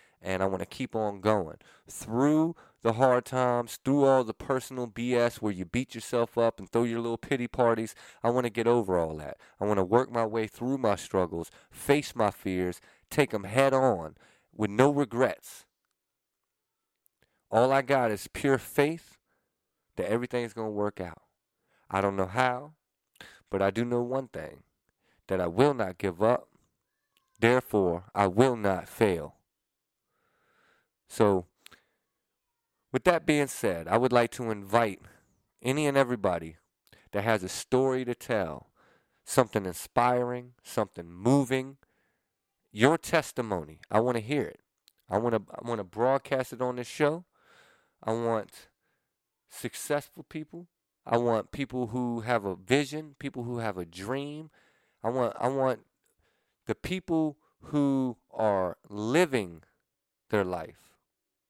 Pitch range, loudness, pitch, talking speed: 105-135 Hz, -29 LUFS, 120 Hz, 150 wpm